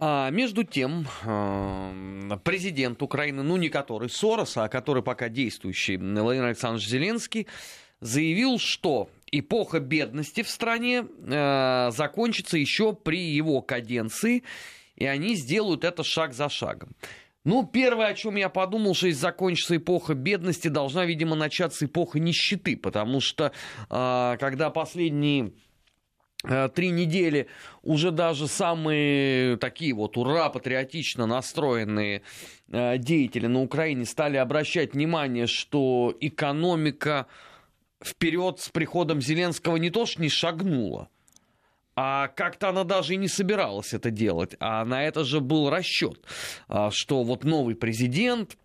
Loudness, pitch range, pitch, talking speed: -26 LUFS, 125-175 Hz, 150 Hz, 125 wpm